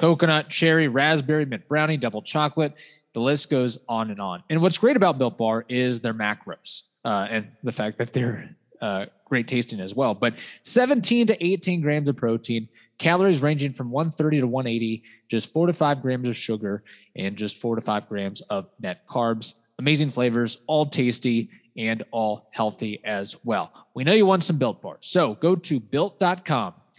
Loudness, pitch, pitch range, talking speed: -24 LUFS, 130 Hz, 115-155 Hz, 180 wpm